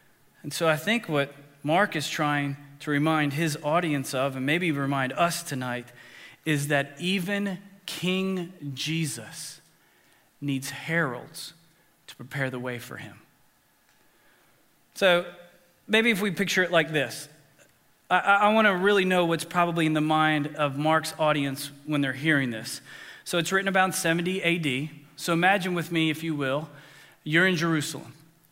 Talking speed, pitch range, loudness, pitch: 155 wpm, 145-175 Hz, -26 LUFS, 155 Hz